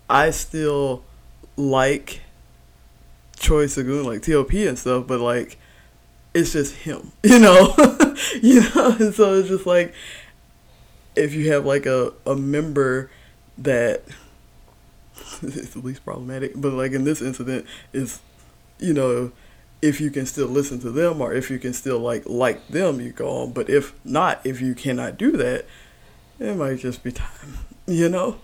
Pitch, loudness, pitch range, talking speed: 135 Hz, -19 LUFS, 125-165 Hz, 165 wpm